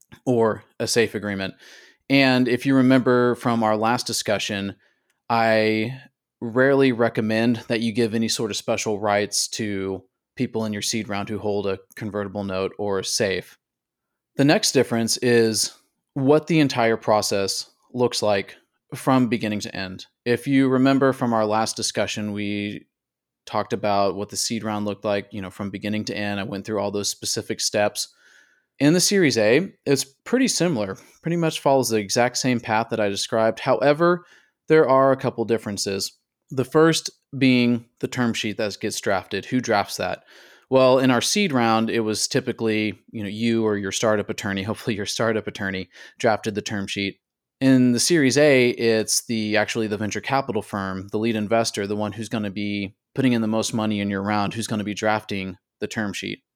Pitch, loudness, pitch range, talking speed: 110 Hz, -22 LUFS, 105-125 Hz, 185 wpm